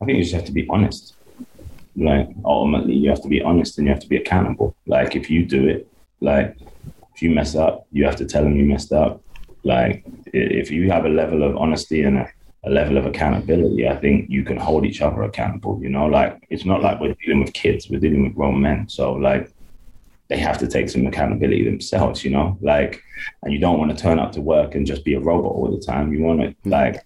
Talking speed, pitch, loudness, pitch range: 240 wpm, 70 Hz, -19 LUFS, 70-80 Hz